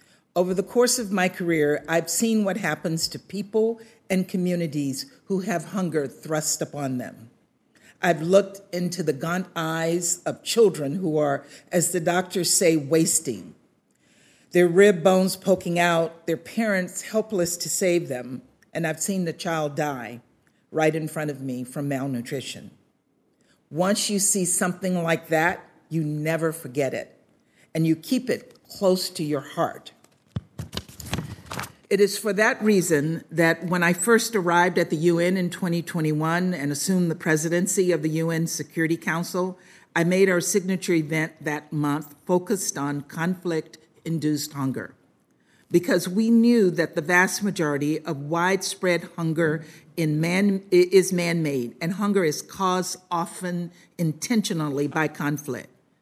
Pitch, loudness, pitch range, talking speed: 170 Hz, -24 LUFS, 155-185 Hz, 145 wpm